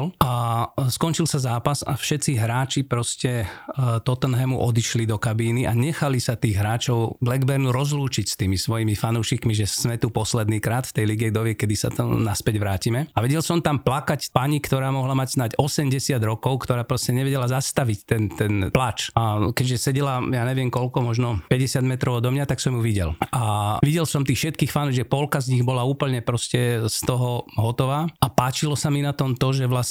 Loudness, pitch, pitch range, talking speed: -23 LUFS, 125 Hz, 115-140 Hz, 195 wpm